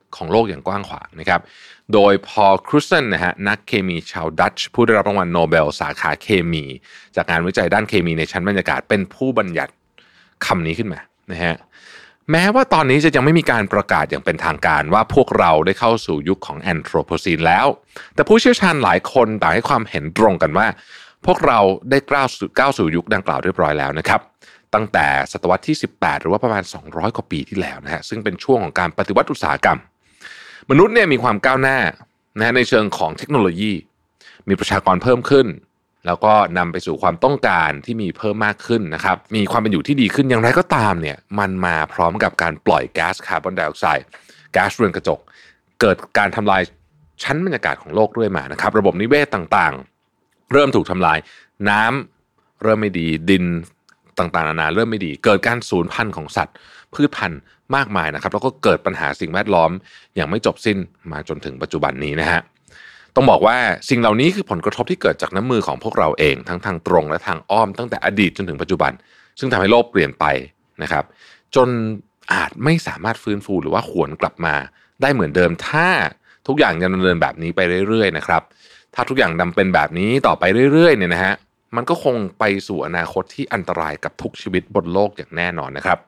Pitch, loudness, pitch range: 100 Hz, -17 LUFS, 85-120 Hz